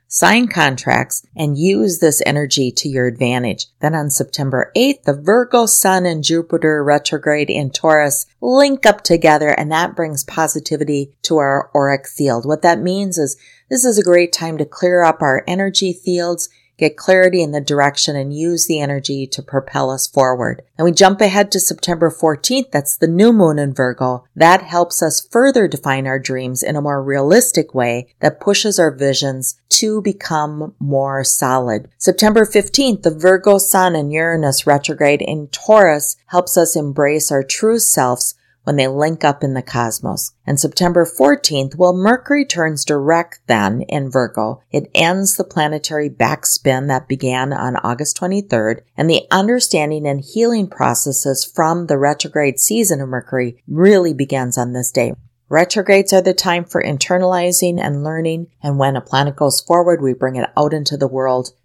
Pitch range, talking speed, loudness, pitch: 135-180 Hz, 170 wpm, -15 LUFS, 150 Hz